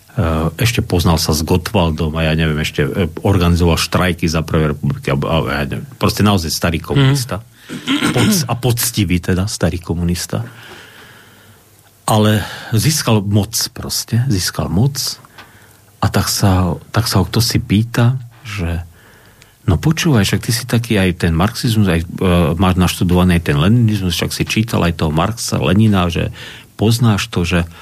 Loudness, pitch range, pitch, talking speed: -15 LUFS, 90-115 Hz, 105 Hz, 140 wpm